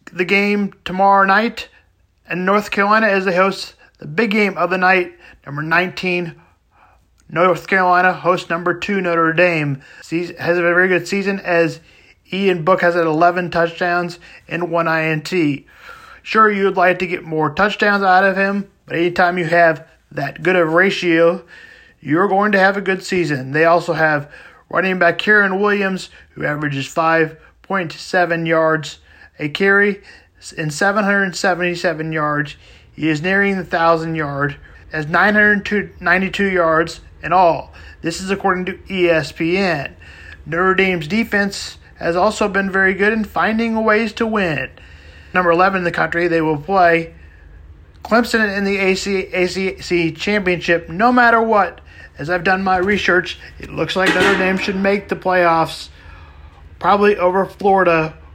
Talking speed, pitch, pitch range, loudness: 150 wpm, 180 Hz, 165-195 Hz, -16 LUFS